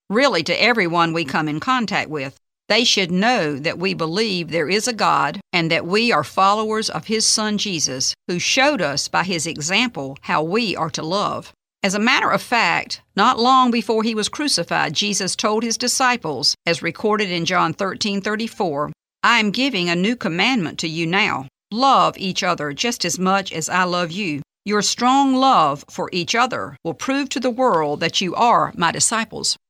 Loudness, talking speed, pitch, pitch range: -18 LUFS, 190 wpm, 195 Hz, 170-230 Hz